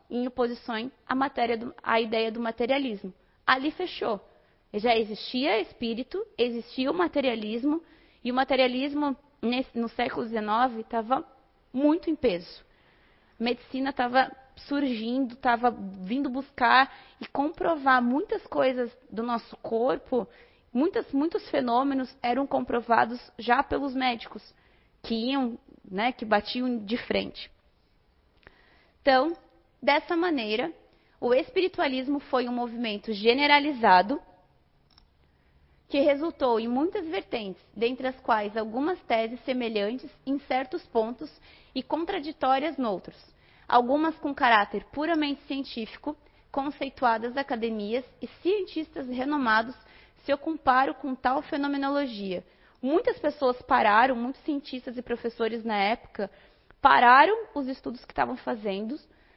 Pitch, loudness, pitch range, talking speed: 260 Hz, -27 LUFS, 235-285 Hz, 115 wpm